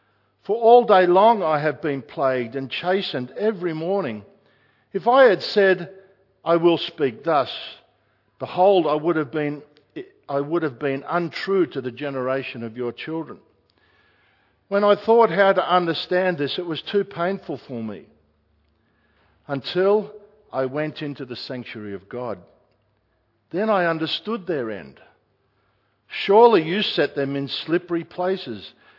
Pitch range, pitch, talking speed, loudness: 130-190 Hz, 155 Hz, 145 wpm, -21 LUFS